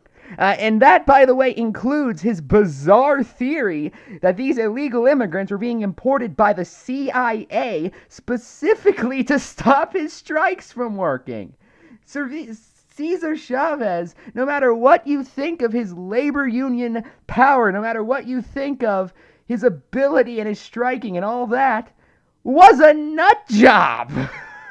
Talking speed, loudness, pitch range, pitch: 140 wpm, -18 LUFS, 220-280 Hz, 250 Hz